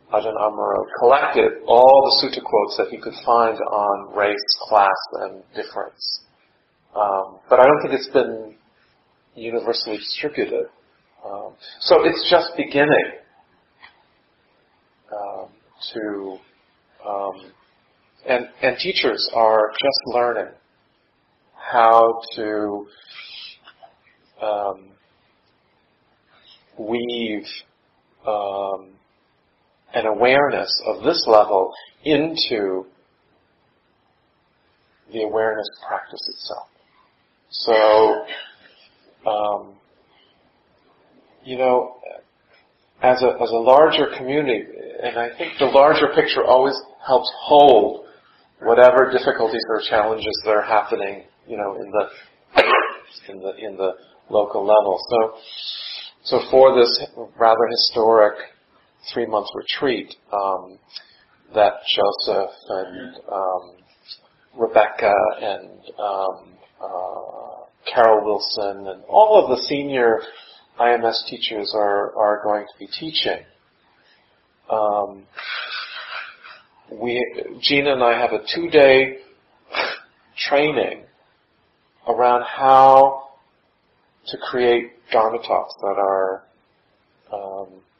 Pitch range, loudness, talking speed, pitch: 100-125 Hz, -18 LUFS, 95 wpm, 115 Hz